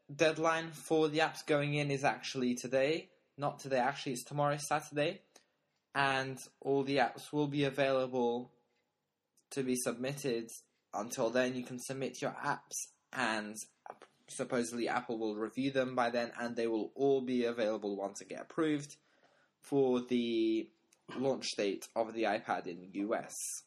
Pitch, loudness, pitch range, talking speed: 130 Hz, -35 LUFS, 120-145 Hz, 150 wpm